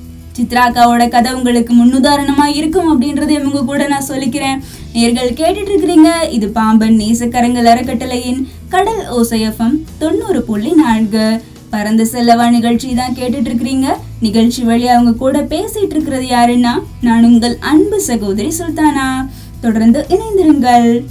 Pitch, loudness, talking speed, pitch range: 245 Hz, -12 LUFS, 120 wpm, 235-290 Hz